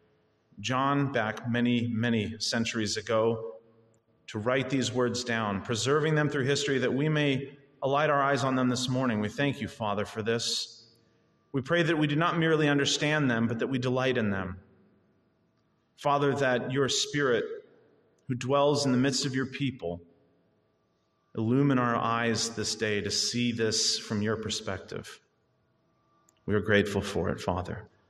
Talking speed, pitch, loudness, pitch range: 160 wpm, 120 Hz, -28 LUFS, 110-140 Hz